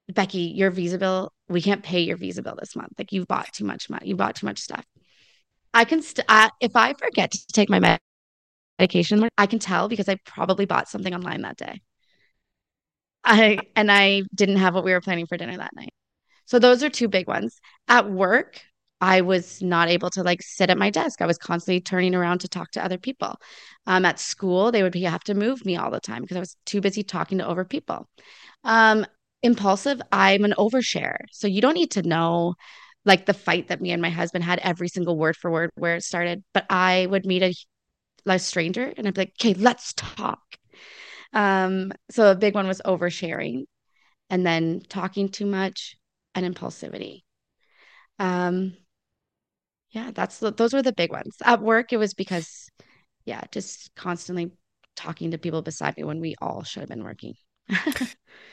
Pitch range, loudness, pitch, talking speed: 175-215 Hz, -22 LUFS, 190 Hz, 200 wpm